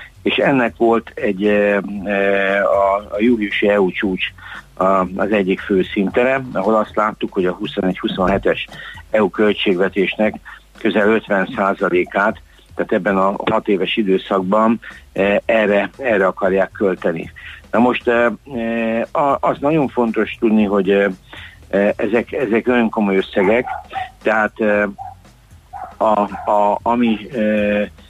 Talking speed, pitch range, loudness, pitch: 105 wpm, 100-115 Hz, -17 LUFS, 105 Hz